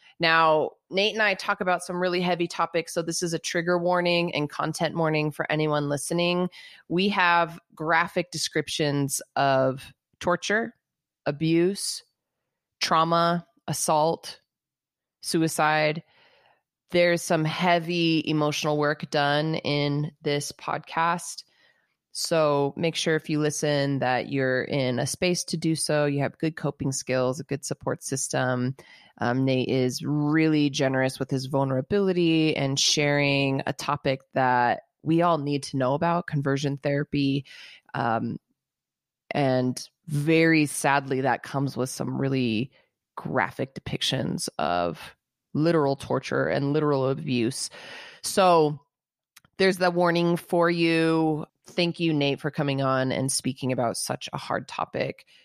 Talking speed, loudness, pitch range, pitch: 130 wpm, -25 LUFS, 140-170 Hz, 150 Hz